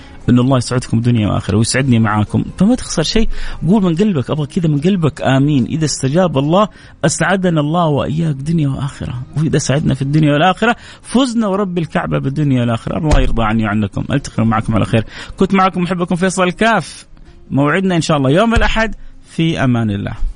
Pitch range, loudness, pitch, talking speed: 120-180 Hz, -15 LUFS, 145 Hz, 170 wpm